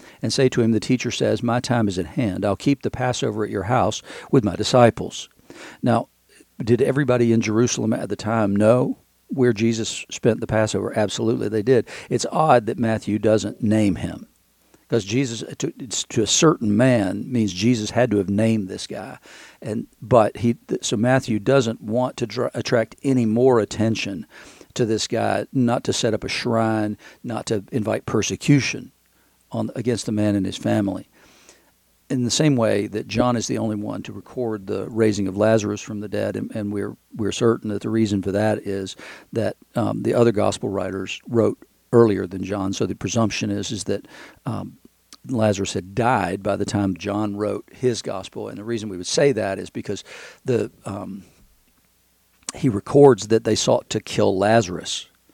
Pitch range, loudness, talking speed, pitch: 105-120 Hz, -21 LUFS, 185 wpm, 110 Hz